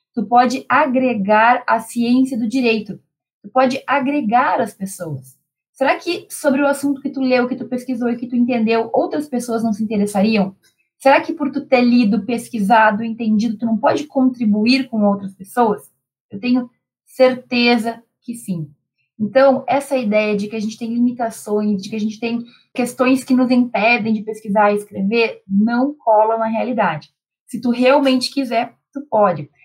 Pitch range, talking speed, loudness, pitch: 215-255 Hz, 170 wpm, -17 LUFS, 235 Hz